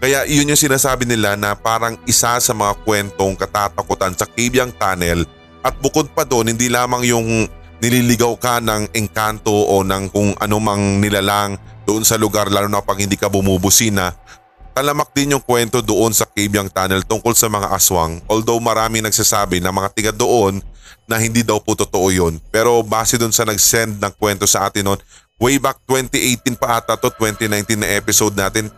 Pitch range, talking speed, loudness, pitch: 100-120 Hz, 175 wpm, -15 LUFS, 110 Hz